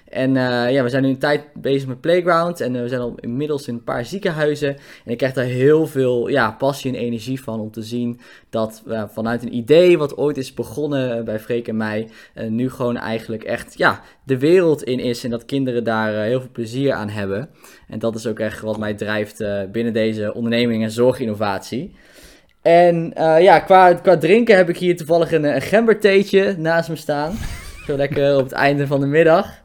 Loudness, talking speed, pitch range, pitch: -18 LUFS, 215 wpm, 115-150 Hz, 130 Hz